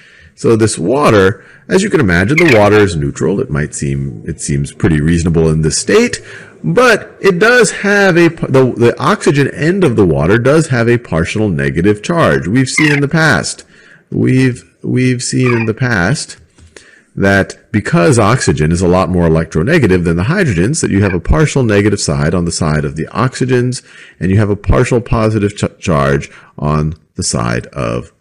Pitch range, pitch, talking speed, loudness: 80-125 Hz, 100 Hz, 185 wpm, -12 LUFS